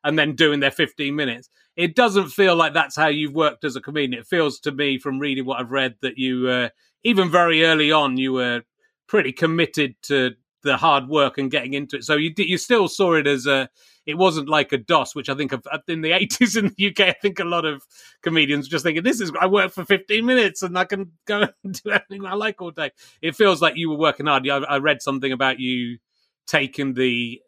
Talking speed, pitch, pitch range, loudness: 235 wpm, 155 Hz, 140-185 Hz, -20 LUFS